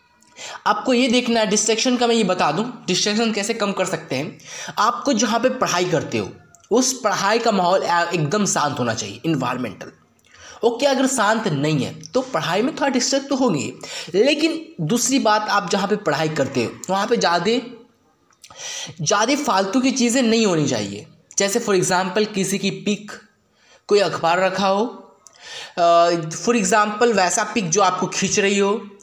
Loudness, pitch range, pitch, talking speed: -19 LUFS, 180-240 Hz, 205 Hz, 165 wpm